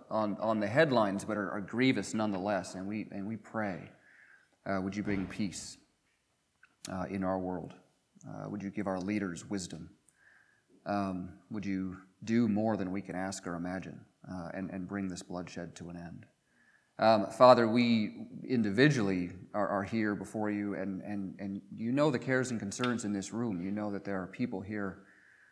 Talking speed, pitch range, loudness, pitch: 185 wpm, 95-105 Hz, -33 LUFS, 100 Hz